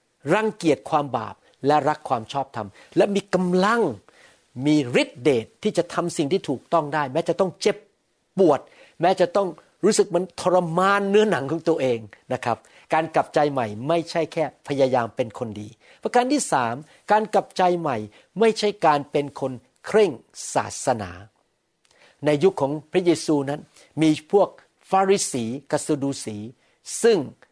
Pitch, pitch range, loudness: 155 Hz, 130-185 Hz, -23 LUFS